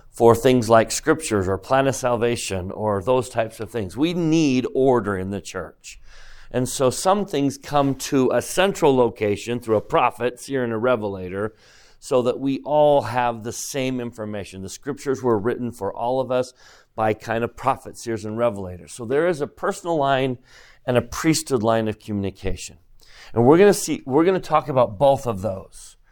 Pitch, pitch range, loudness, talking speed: 120 Hz, 110-135 Hz, -21 LUFS, 190 wpm